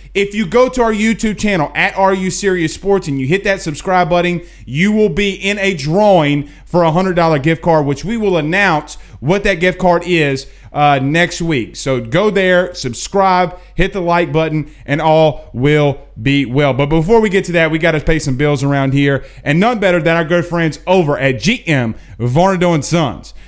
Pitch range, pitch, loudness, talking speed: 145-190 Hz, 170 Hz, -14 LUFS, 205 wpm